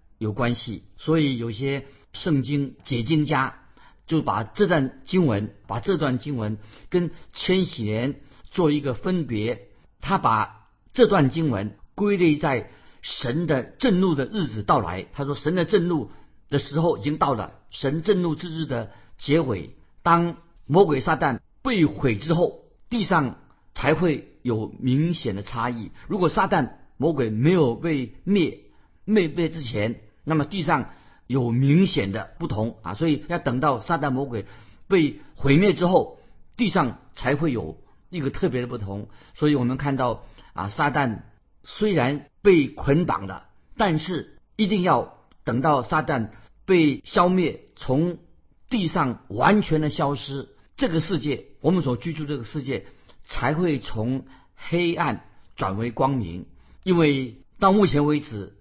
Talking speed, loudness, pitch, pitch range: 210 characters per minute, -24 LUFS, 145 Hz, 120-170 Hz